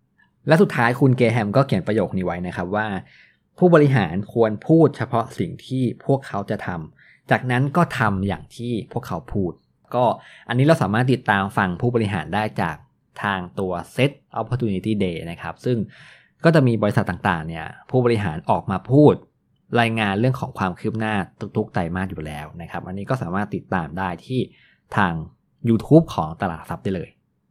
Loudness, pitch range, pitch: -21 LUFS, 95-125 Hz, 110 Hz